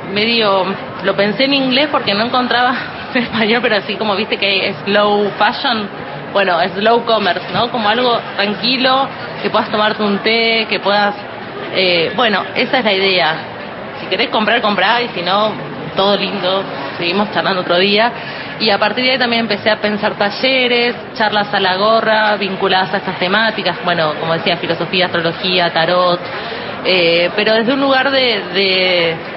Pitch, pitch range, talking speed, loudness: 205 Hz, 185-230 Hz, 170 wpm, -14 LUFS